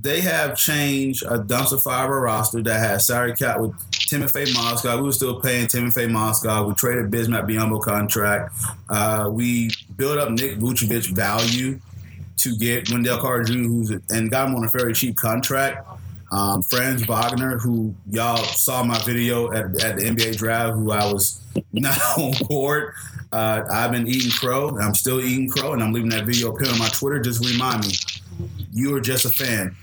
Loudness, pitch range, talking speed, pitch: -20 LUFS, 110-125 Hz, 185 wpm, 115 Hz